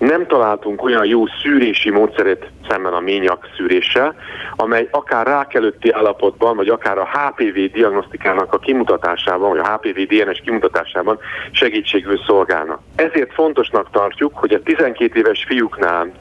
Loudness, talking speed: -16 LUFS, 135 wpm